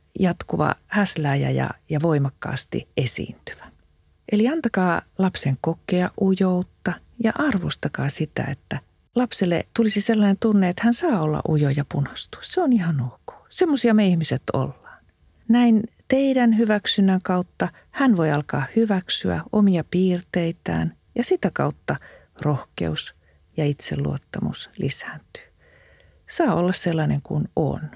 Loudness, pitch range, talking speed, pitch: -22 LUFS, 150-225 Hz, 120 wpm, 180 Hz